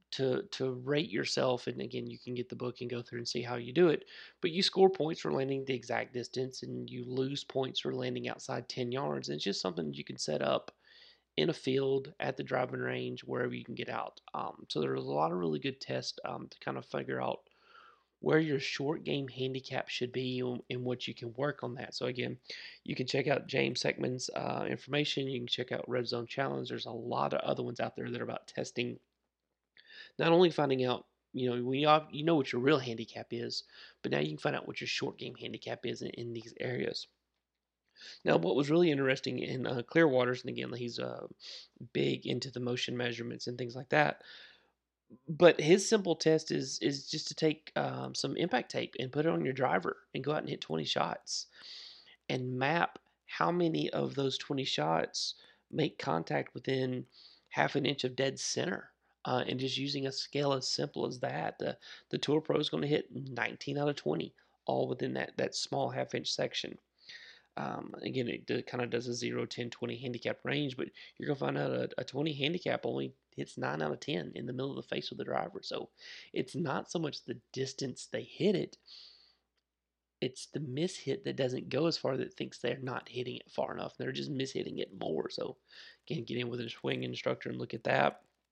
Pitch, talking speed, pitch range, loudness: 125 Hz, 220 wpm, 115-140 Hz, -34 LUFS